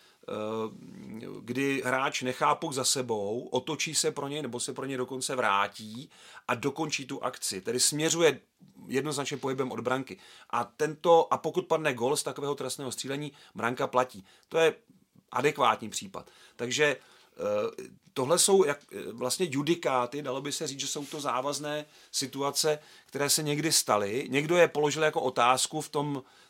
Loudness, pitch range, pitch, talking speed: -29 LUFS, 130-155 Hz, 140 Hz, 155 wpm